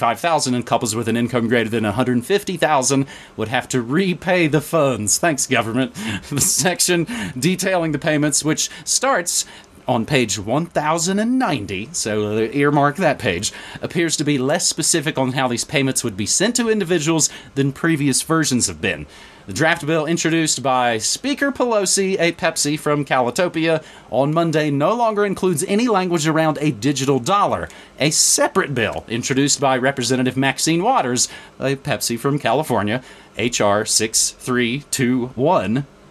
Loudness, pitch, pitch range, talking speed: -18 LUFS, 145 Hz, 125-170 Hz, 140 wpm